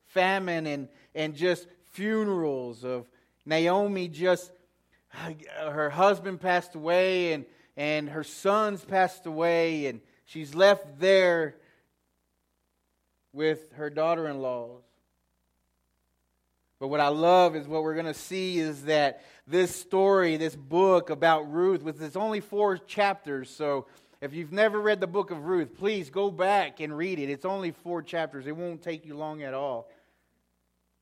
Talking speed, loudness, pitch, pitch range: 145 wpm, -27 LUFS, 160 Hz, 140-180 Hz